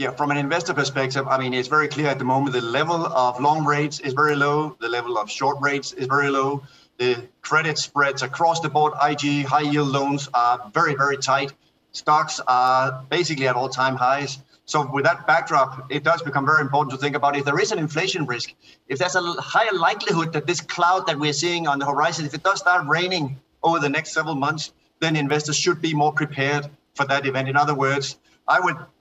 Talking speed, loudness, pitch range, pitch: 220 wpm, -21 LUFS, 135-155 Hz, 145 Hz